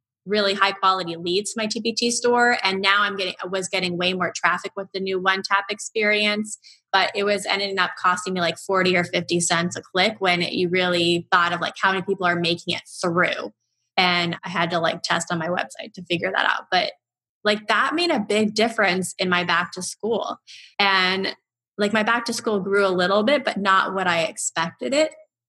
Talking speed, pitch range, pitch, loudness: 220 wpm, 175-210 Hz, 190 Hz, -21 LUFS